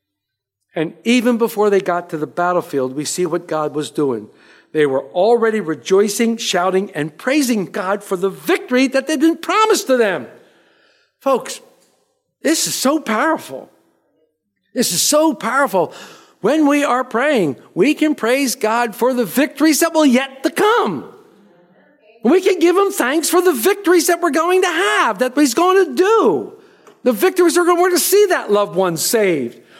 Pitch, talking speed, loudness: 255 Hz, 170 wpm, -16 LUFS